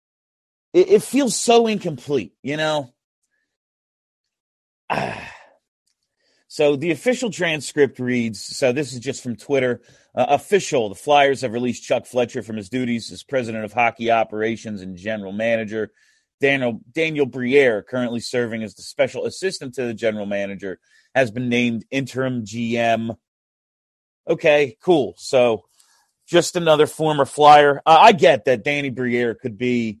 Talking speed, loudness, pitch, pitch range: 140 wpm, -19 LUFS, 125 Hz, 115-145 Hz